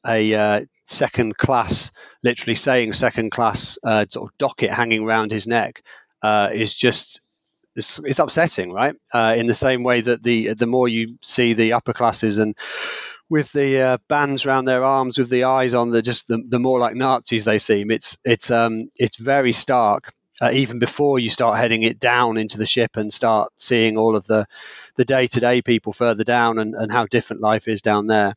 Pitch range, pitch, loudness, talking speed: 110-125 Hz, 120 Hz, -18 LUFS, 200 wpm